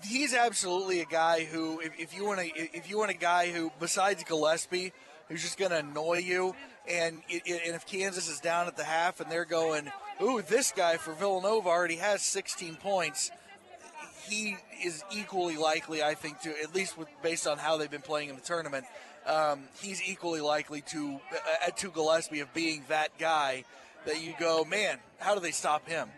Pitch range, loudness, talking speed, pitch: 155-190 Hz, -31 LUFS, 195 wpm, 170 Hz